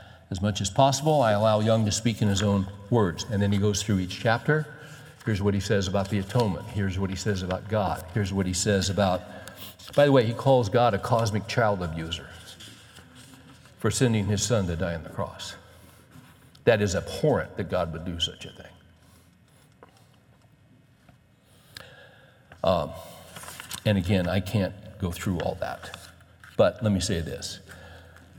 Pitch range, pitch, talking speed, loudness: 95-115 Hz, 100 Hz, 170 wpm, -26 LUFS